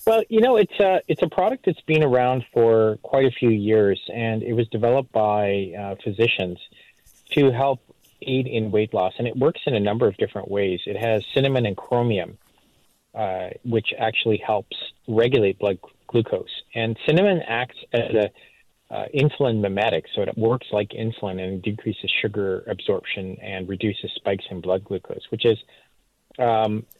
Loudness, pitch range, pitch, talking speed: -22 LUFS, 100-130 Hz, 115 Hz, 170 wpm